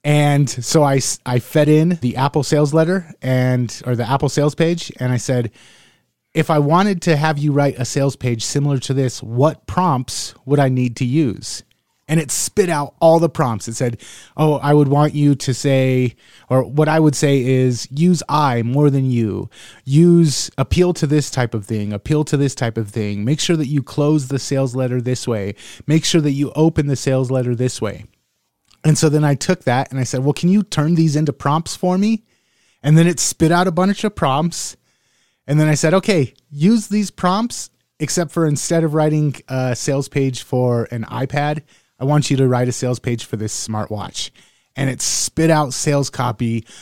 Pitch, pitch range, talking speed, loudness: 140 Hz, 125-155 Hz, 210 wpm, -17 LUFS